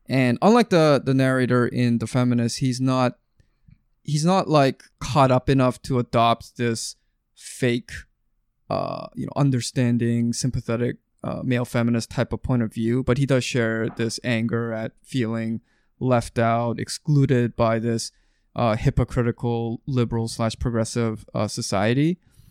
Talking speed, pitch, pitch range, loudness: 140 wpm, 120 Hz, 115-130 Hz, -22 LUFS